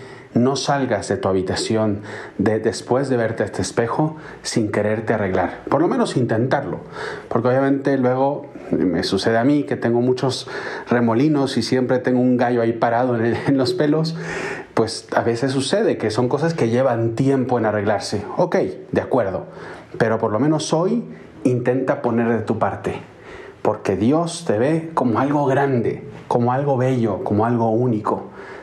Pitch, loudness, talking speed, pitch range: 125 Hz, -20 LUFS, 170 wpm, 115-135 Hz